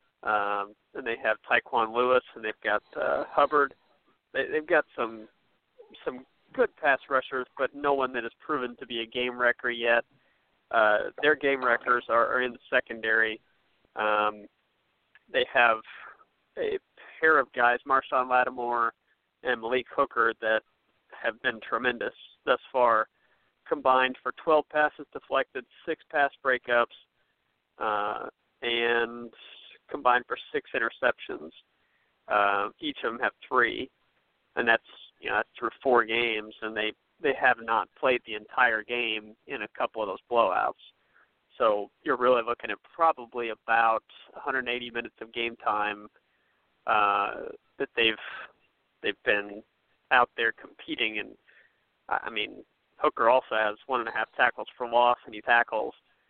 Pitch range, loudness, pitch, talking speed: 115-130 Hz, -27 LUFS, 120 Hz, 145 wpm